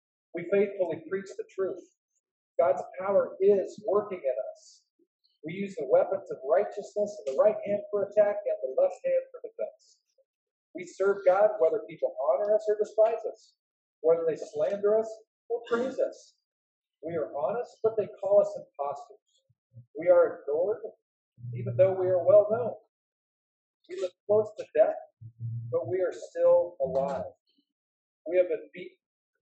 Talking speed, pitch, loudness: 155 wpm, 220 Hz, -28 LUFS